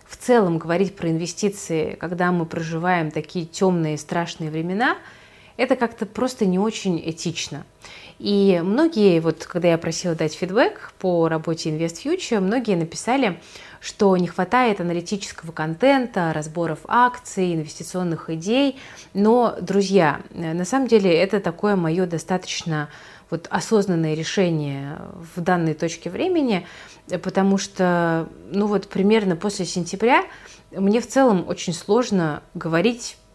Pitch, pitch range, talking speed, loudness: 180 Hz, 165-210 Hz, 130 wpm, -21 LUFS